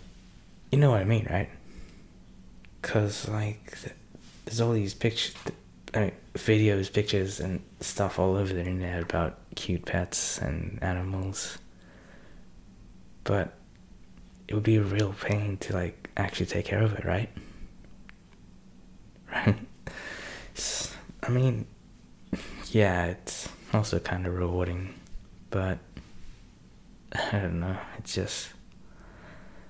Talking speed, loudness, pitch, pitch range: 115 wpm, -30 LUFS, 100 Hz, 90-110 Hz